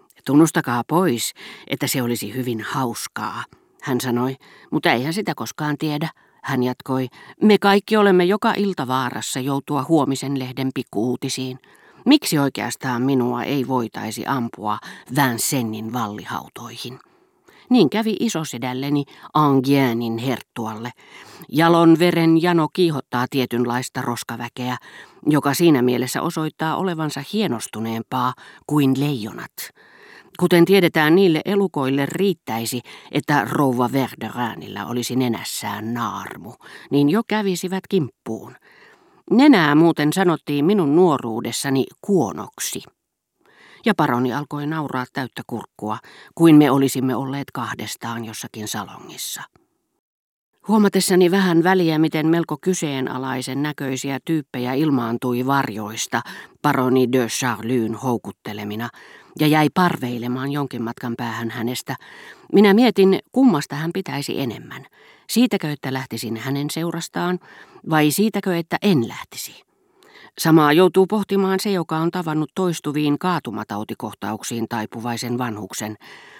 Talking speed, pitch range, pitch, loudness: 105 wpm, 120-175 Hz, 140 Hz, -20 LUFS